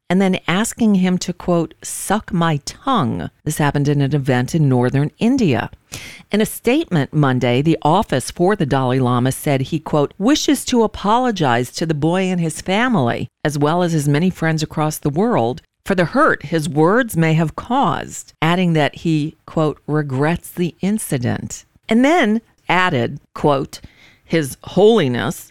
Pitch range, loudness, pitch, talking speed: 145-190 Hz, -17 LUFS, 160 Hz, 160 wpm